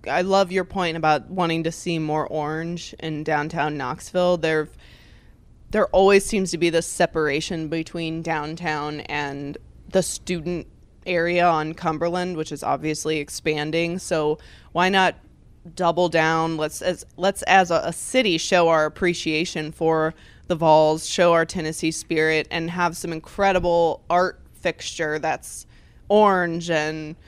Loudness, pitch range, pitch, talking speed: -22 LUFS, 155-180 Hz, 165 Hz, 140 wpm